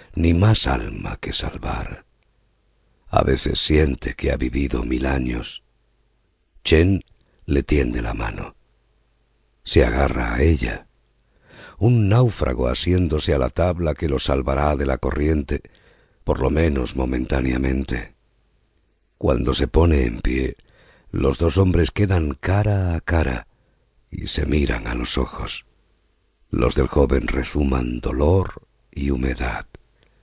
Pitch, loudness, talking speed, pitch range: 75 Hz, -21 LUFS, 125 wpm, 65-85 Hz